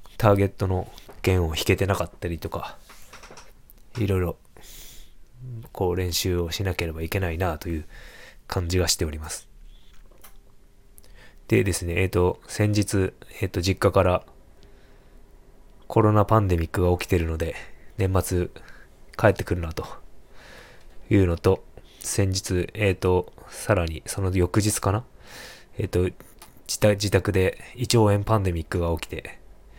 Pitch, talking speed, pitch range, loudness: 95 Hz, 265 characters per minute, 85-105 Hz, -24 LUFS